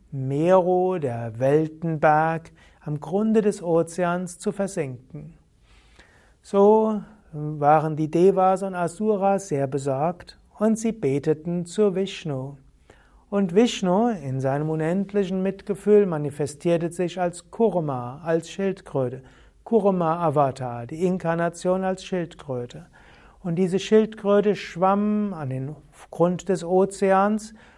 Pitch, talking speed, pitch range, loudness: 175 Hz, 105 wpm, 150-195 Hz, -23 LUFS